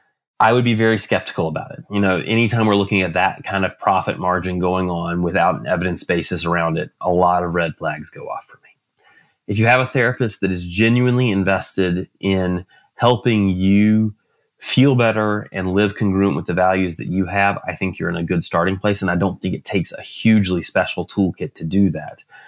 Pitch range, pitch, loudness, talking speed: 90-110 Hz, 95 Hz, -18 LUFS, 210 wpm